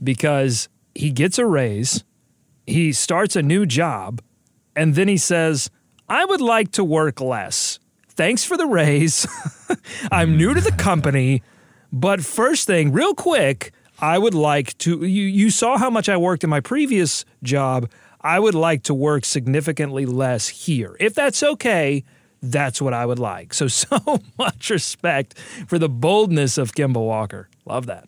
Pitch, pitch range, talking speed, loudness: 150 Hz, 130-195 Hz, 165 wpm, -19 LUFS